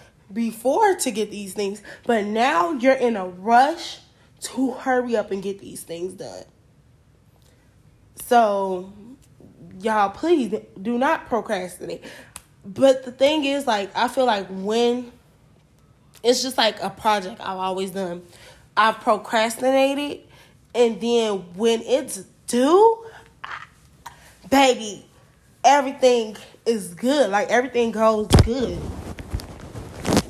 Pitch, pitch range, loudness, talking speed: 225 Hz, 195-255 Hz, -21 LUFS, 115 wpm